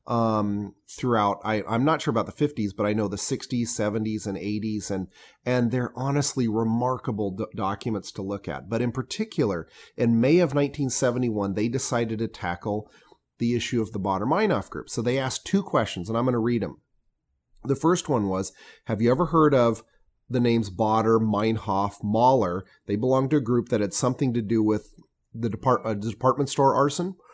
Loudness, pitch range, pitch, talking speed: -25 LUFS, 105-130 Hz, 115 Hz, 190 wpm